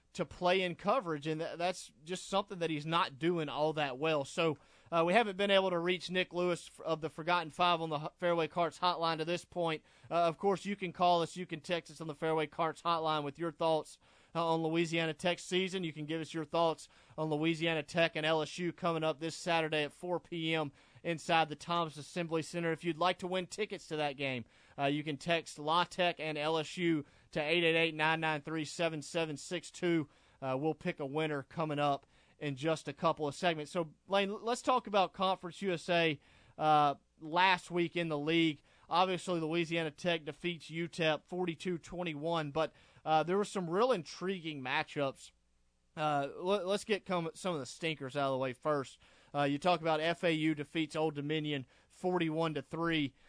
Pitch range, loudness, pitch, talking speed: 155-175 Hz, -35 LUFS, 165 Hz, 190 wpm